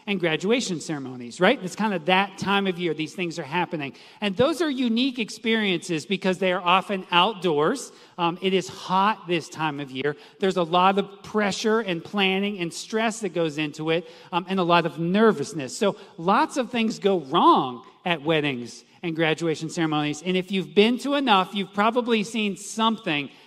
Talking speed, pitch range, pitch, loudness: 185 wpm, 165-205 Hz, 185 Hz, -24 LUFS